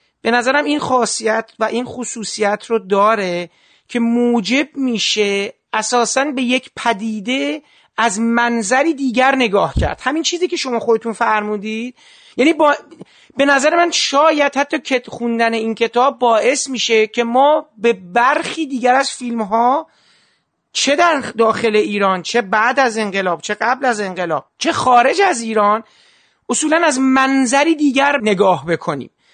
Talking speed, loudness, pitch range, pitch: 145 wpm, -16 LUFS, 220-275 Hz, 240 Hz